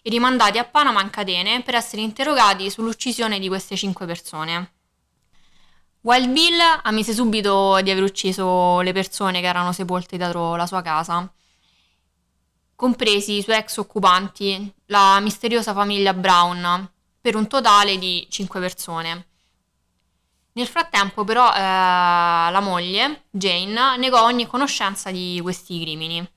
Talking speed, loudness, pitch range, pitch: 130 wpm, -19 LUFS, 180-225 Hz, 195 Hz